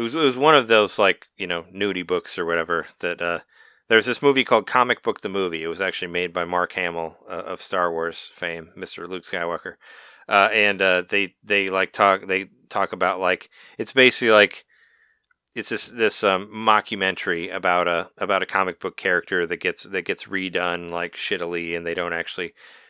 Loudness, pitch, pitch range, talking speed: -21 LUFS, 95 Hz, 85-105 Hz, 200 wpm